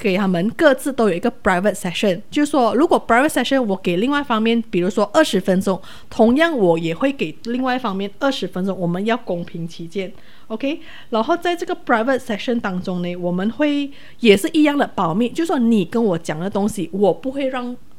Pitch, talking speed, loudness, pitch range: 225 Hz, 420 characters per minute, -19 LUFS, 190-265 Hz